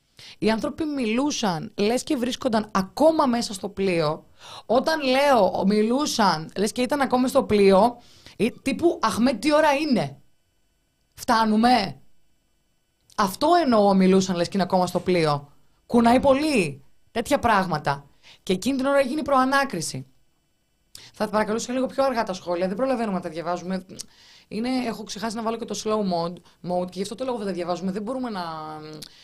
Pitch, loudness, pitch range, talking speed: 215 Hz, -23 LUFS, 180-255 Hz, 160 wpm